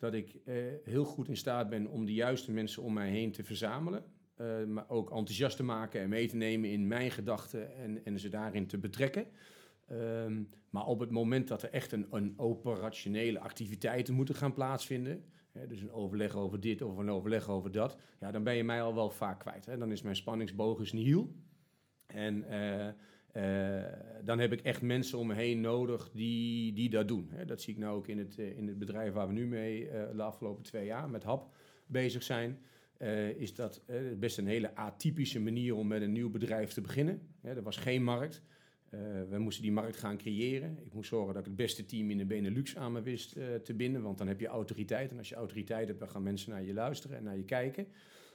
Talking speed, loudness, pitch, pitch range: 225 wpm, -38 LUFS, 110 Hz, 105-125 Hz